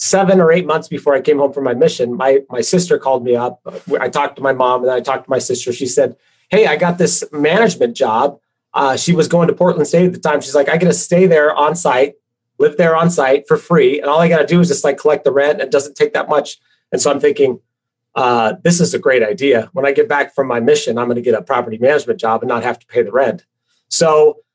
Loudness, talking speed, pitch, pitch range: -14 LUFS, 270 wpm, 155 Hz, 135-185 Hz